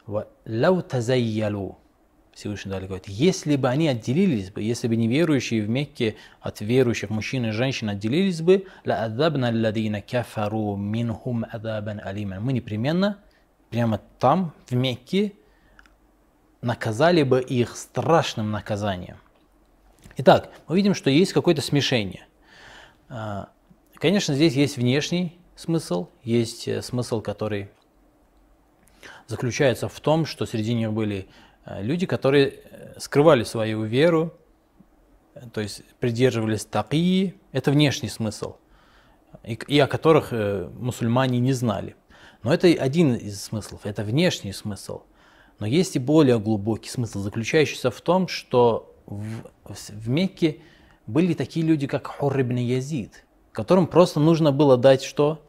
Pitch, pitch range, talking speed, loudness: 125 Hz, 110-155 Hz, 115 wpm, -23 LUFS